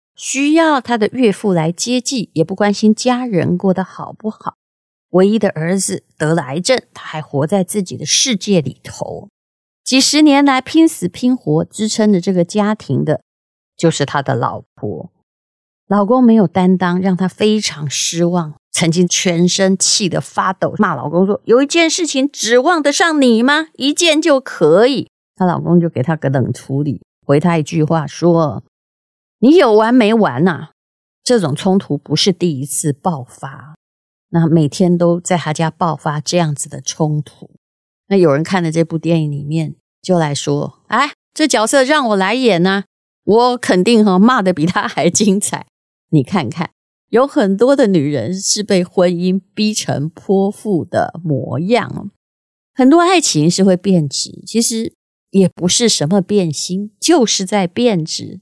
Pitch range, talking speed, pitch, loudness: 160-220 Hz, 235 characters per minute, 185 Hz, -14 LUFS